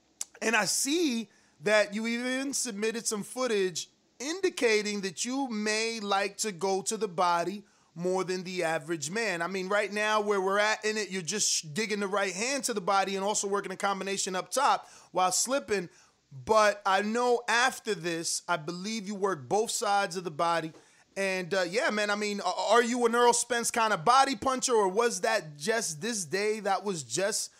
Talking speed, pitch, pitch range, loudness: 195 wpm, 205 Hz, 190-230 Hz, -29 LUFS